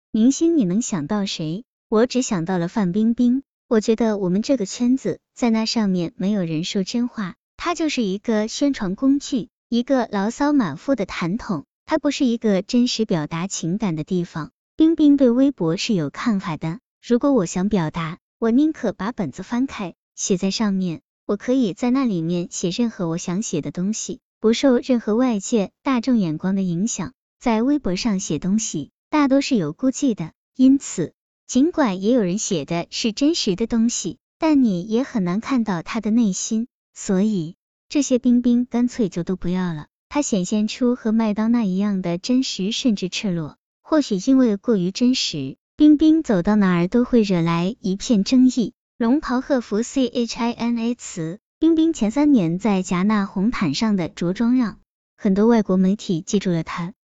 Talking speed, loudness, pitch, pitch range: 265 characters per minute, -21 LUFS, 220 Hz, 185-250 Hz